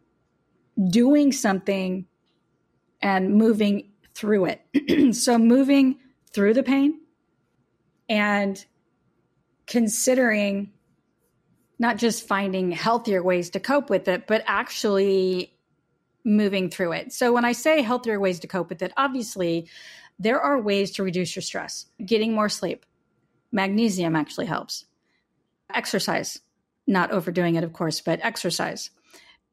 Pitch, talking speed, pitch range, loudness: 205 Hz, 120 wpm, 185-240 Hz, -23 LUFS